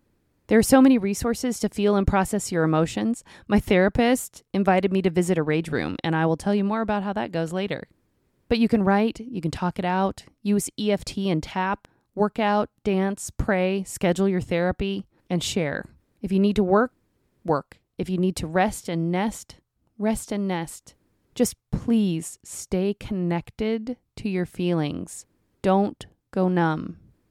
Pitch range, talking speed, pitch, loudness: 180-210 Hz, 175 wpm, 195 Hz, -24 LUFS